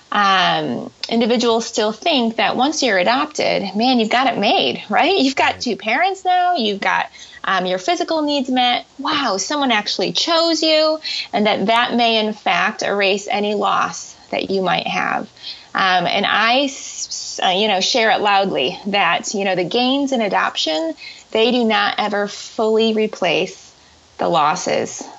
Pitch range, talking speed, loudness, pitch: 205-285 Hz, 160 wpm, -17 LUFS, 235 Hz